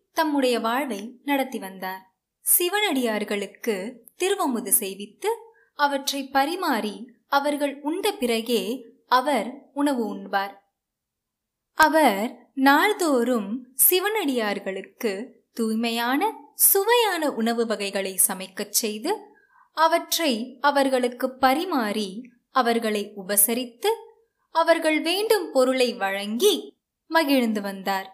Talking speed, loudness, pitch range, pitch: 75 wpm, -23 LUFS, 220-315 Hz, 255 Hz